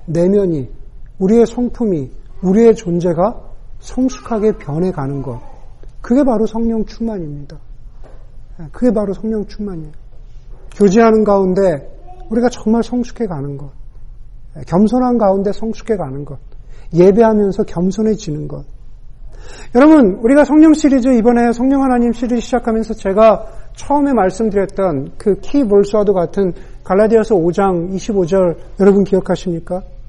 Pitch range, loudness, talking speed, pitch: 145-225 Hz, -14 LUFS, 295 characters per minute, 195 Hz